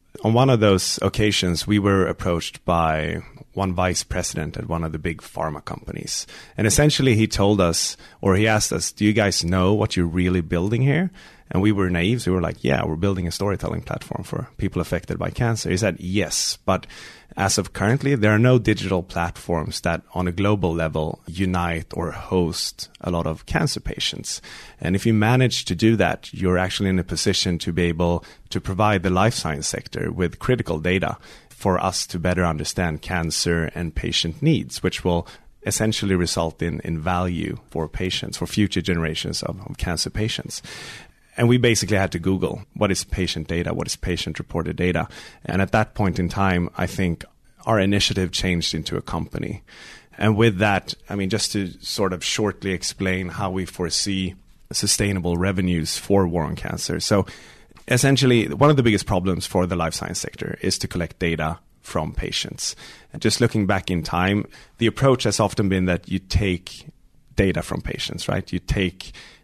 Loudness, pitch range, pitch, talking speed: -22 LUFS, 85-105 Hz, 95 Hz, 190 wpm